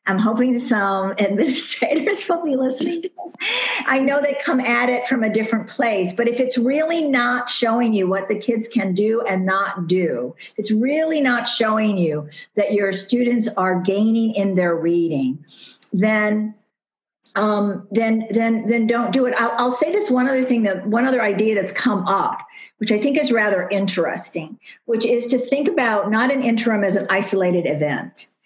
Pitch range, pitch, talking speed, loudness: 195-250 Hz, 225 Hz, 185 wpm, -19 LUFS